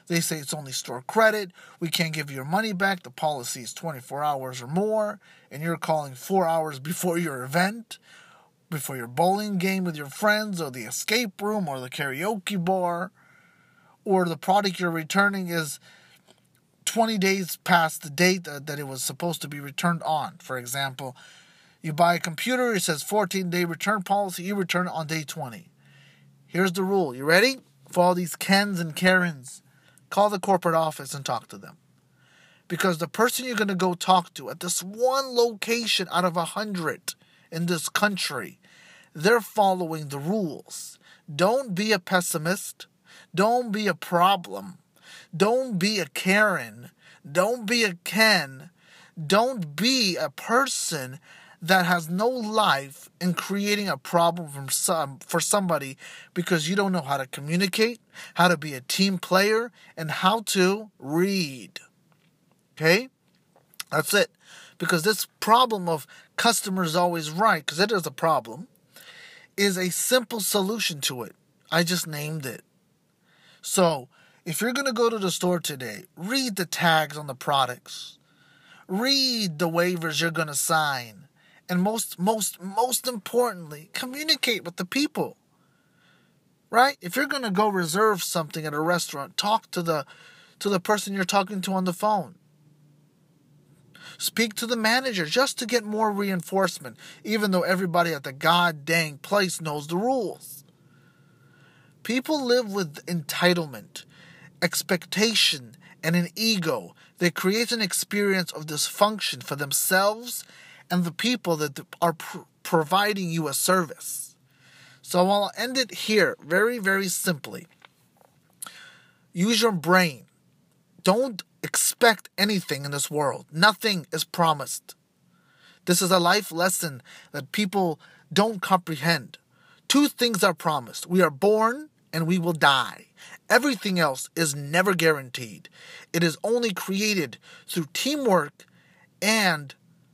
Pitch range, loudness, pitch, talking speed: 160-205 Hz, -24 LUFS, 180 Hz, 145 wpm